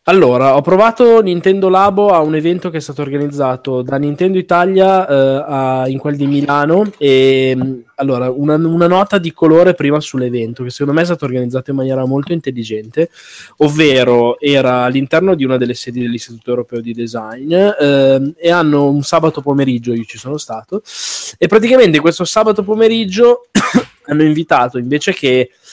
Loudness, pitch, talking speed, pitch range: -12 LUFS, 145 Hz, 165 wpm, 130-175 Hz